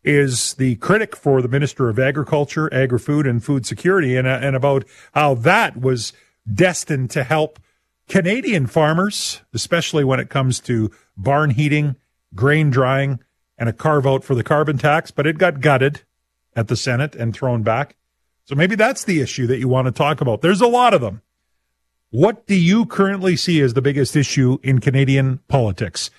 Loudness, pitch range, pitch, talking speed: -18 LUFS, 125-155 Hz, 140 Hz, 180 wpm